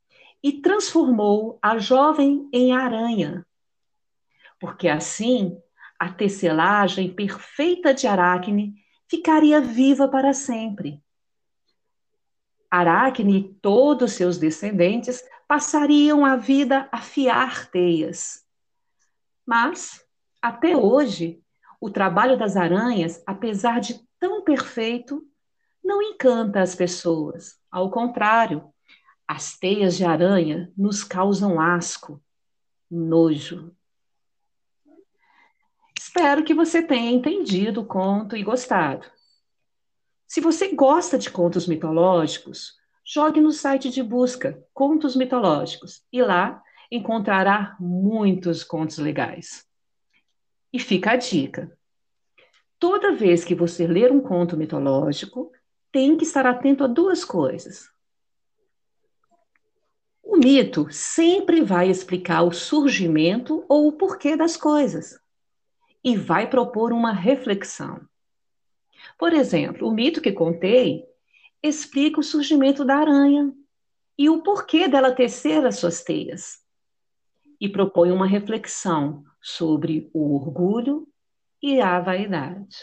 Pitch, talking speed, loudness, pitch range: 240 Hz, 105 wpm, -21 LUFS, 180-295 Hz